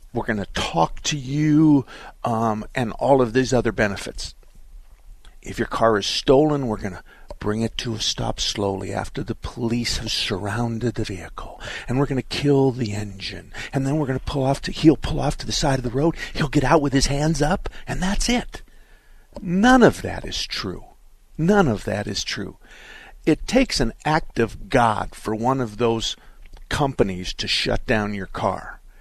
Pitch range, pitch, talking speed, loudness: 105-145 Hz, 120 Hz, 190 wpm, -22 LUFS